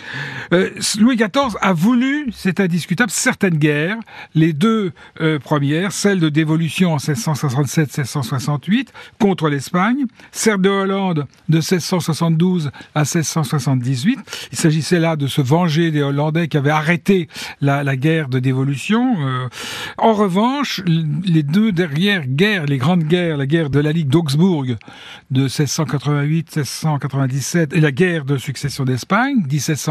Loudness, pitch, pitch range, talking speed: -17 LUFS, 160 Hz, 145-190 Hz, 135 wpm